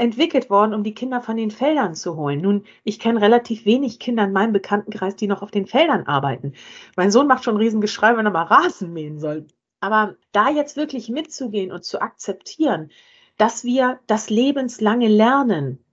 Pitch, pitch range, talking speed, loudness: 215 Hz, 200-250 Hz, 185 wpm, -19 LUFS